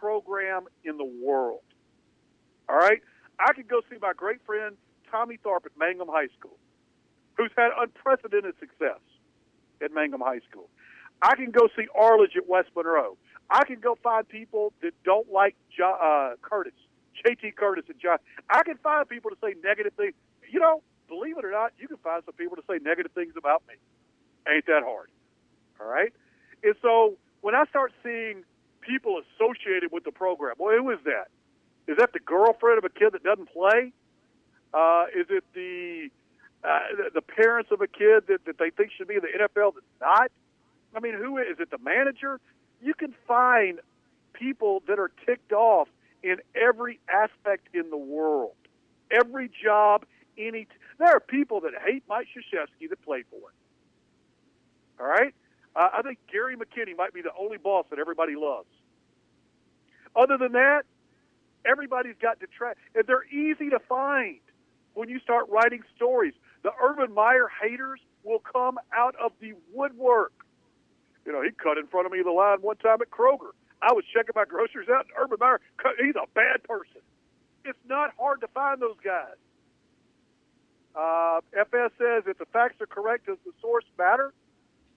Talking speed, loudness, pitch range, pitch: 175 wpm, -25 LUFS, 200-275 Hz, 235 Hz